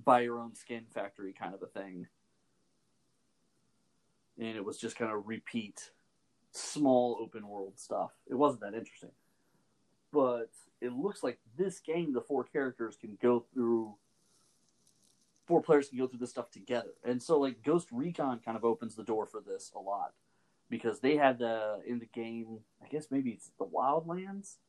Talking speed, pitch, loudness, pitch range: 175 wpm, 120 Hz, -35 LUFS, 110-135 Hz